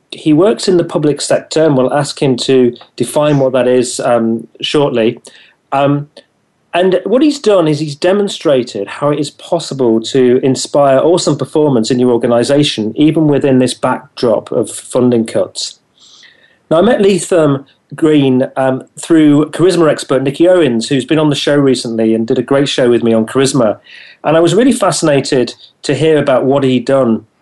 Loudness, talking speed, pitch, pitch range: -12 LUFS, 175 wpm, 140 Hz, 125-160 Hz